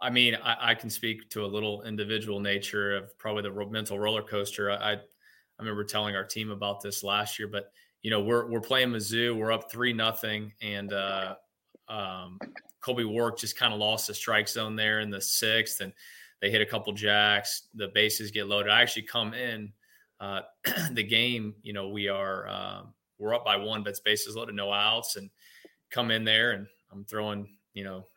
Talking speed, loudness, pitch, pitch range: 205 wpm, -28 LUFS, 105 Hz, 100-110 Hz